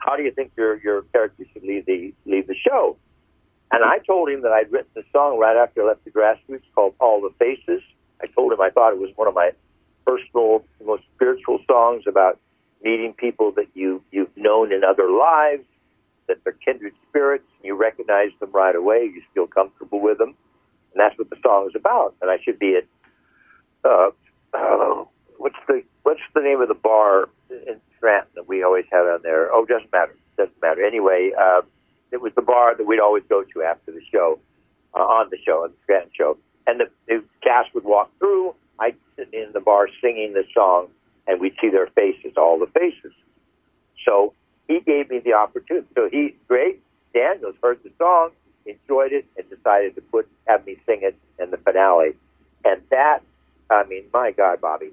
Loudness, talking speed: -19 LUFS, 200 wpm